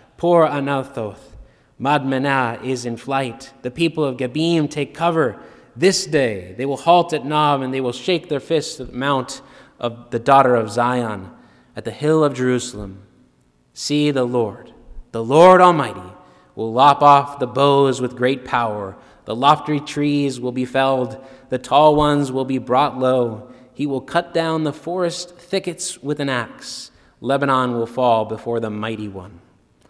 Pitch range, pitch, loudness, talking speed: 120-150 Hz, 135 Hz, -18 LUFS, 165 wpm